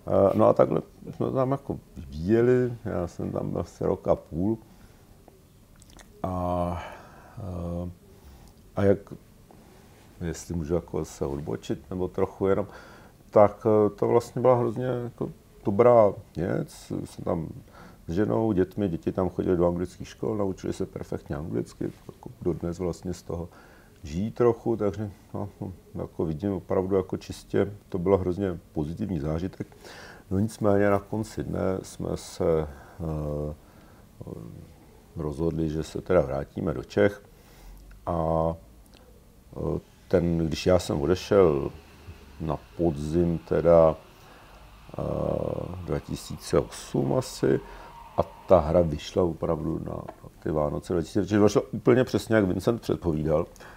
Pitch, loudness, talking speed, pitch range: 95 Hz, -27 LUFS, 125 wpm, 85-105 Hz